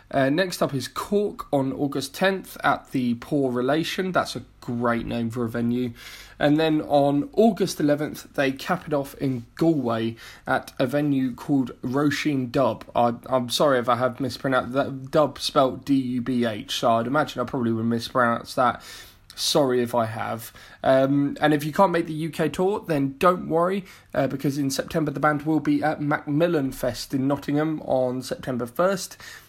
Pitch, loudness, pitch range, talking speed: 140 Hz, -24 LUFS, 125-155 Hz, 175 wpm